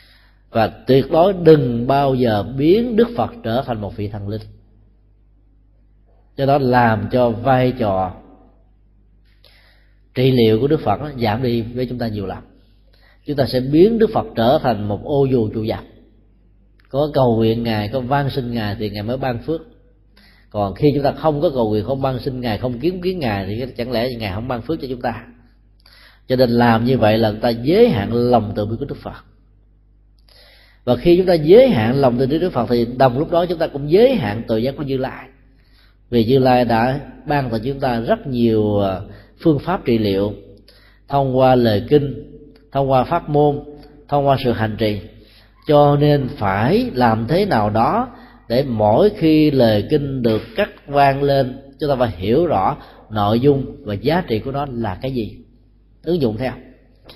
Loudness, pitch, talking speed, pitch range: -17 LUFS, 120 Hz, 195 wpm, 105-140 Hz